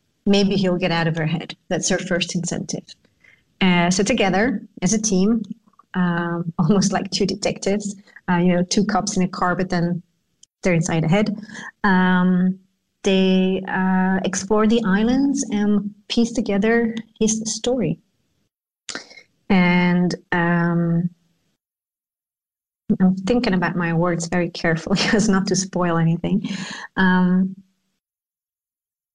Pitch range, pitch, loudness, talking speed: 175-210 Hz, 190 Hz, -20 LUFS, 130 wpm